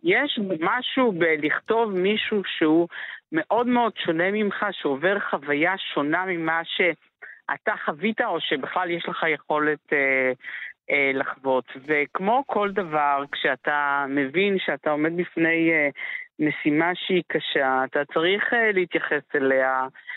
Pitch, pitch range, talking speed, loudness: 165 Hz, 145-200 Hz, 120 wpm, -23 LUFS